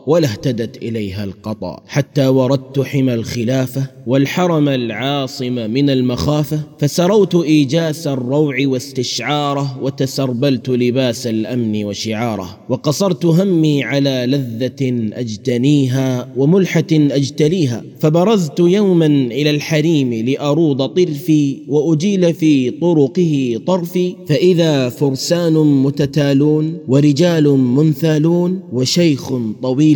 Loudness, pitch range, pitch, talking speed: -15 LUFS, 130-155 Hz, 140 Hz, 90 wpm